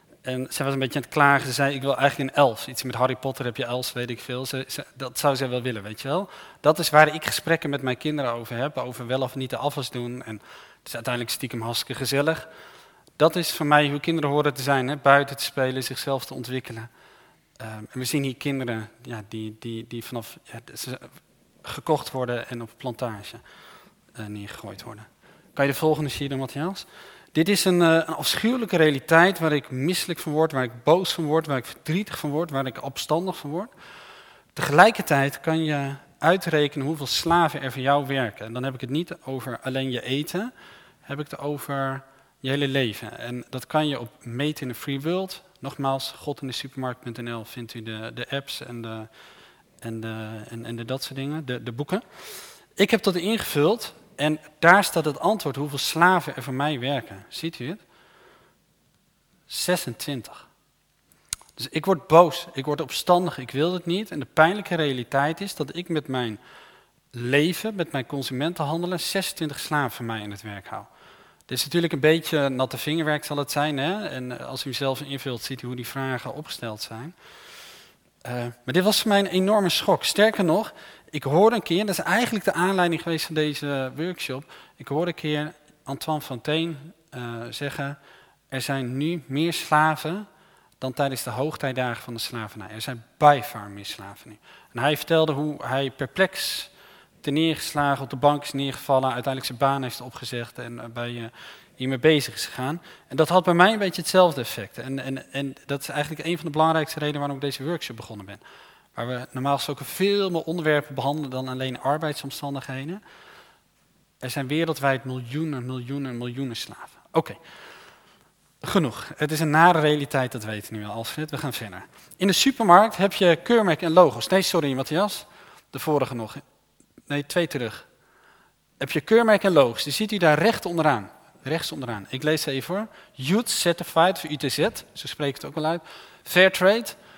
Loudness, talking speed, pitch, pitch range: -24 LUFS, 195 wpm, 140 Hz, 130-160 Hz